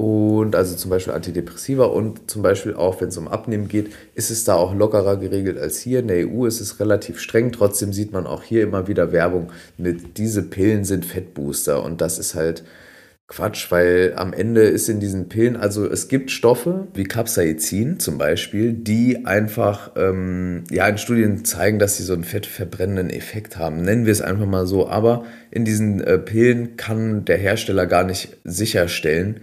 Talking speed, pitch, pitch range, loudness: 190 wpm, 100 Hz, 90-110 Hz, -20 LUFS